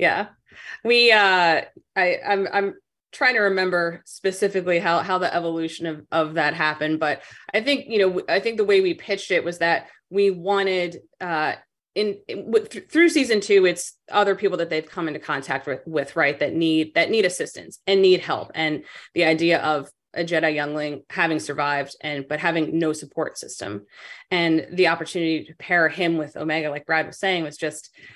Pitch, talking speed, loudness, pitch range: 170 Hz, 190 wpm, -22 LUFS, 155-195 Hz